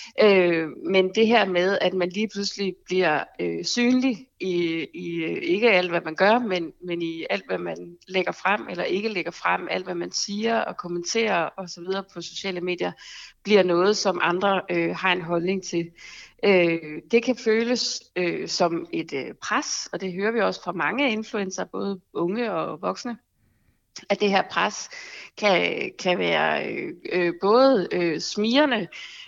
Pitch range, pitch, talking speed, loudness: 175-220 Hz, 190 Hz, 170 wpm, -24 LUFS